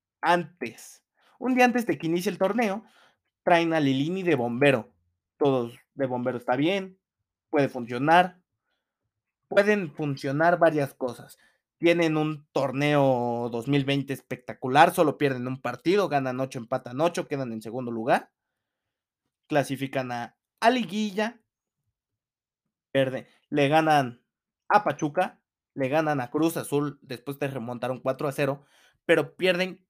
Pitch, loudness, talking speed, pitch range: 145 Hz, -26 LUFS, 125 wpm, 130-170 Hz